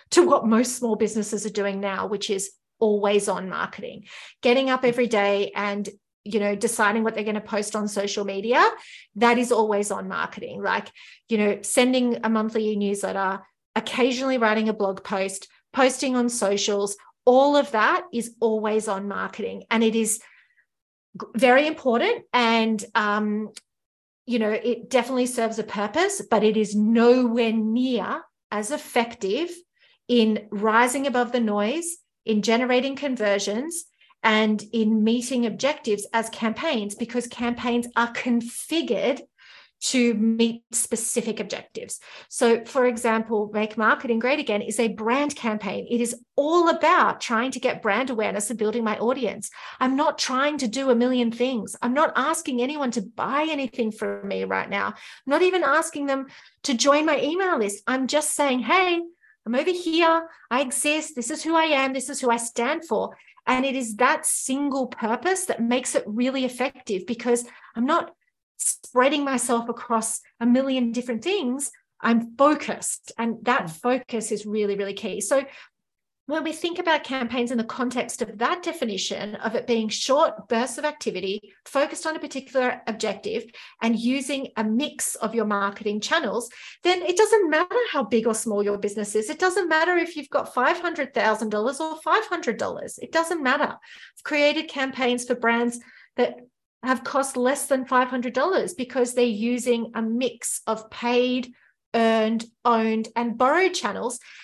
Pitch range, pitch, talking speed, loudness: 220-275 Hz, 240 Hz, 160 wpm, -23 LUFS